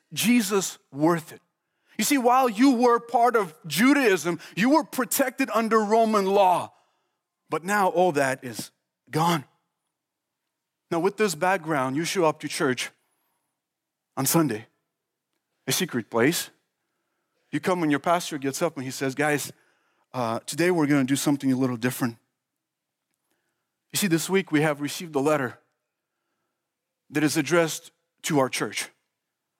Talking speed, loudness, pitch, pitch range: 150 wpm, -24 LUFS, 165 Hz, 145-195 Hz